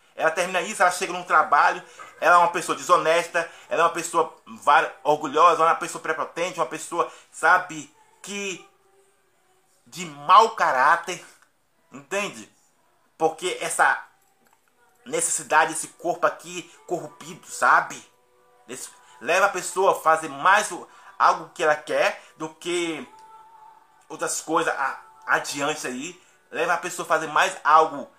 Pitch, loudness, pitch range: 175 Hz, -22 LUFS, 160-210 Hz